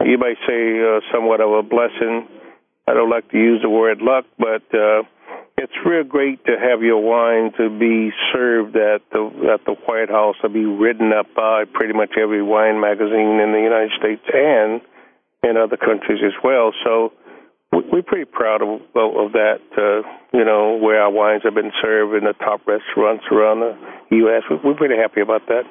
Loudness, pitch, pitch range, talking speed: -17 LUFS, 110 Hz, 110-115 Hz, 190 wpm